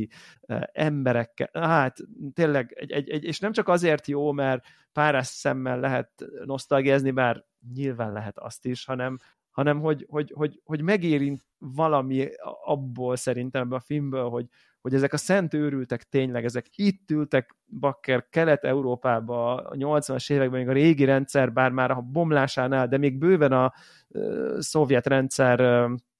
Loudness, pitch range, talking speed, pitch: -25 LUFS, 125-150 Hz, 145 wpm, 135 Hz